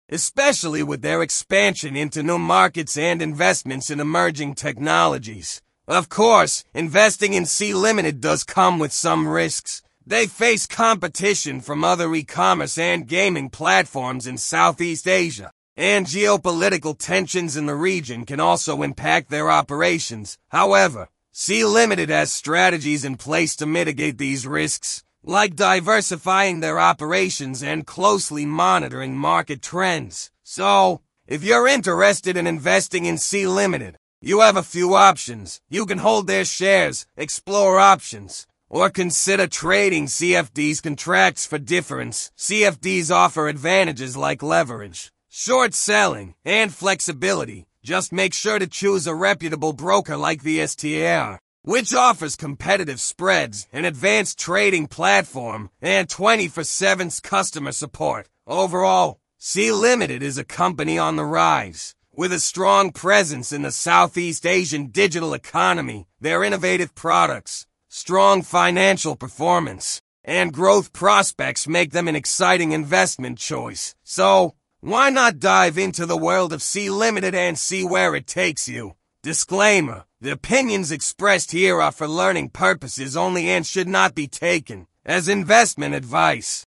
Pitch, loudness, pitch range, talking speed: 175 Hz, -19 LUFS, 150-195 Hz, 130 wpm